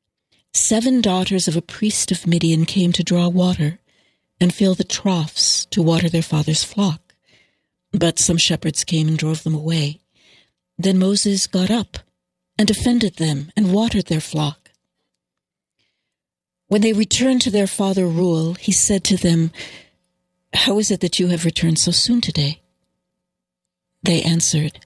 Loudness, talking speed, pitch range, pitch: -18 LUFS, 150 wpm, 160-195 Hz, 175 Hz